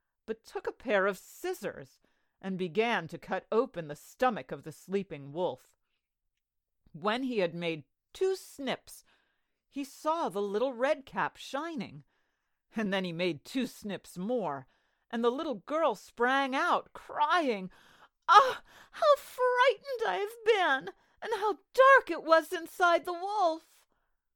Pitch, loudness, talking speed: 260 Hz, -30 LUFS, 145 wpm